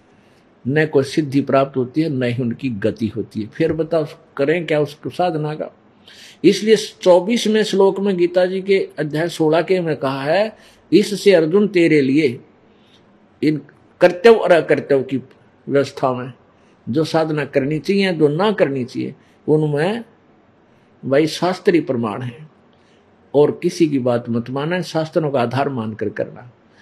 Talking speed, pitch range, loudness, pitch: 150 wpm, 130-175 Hz, -18 LUFS, 150 Hz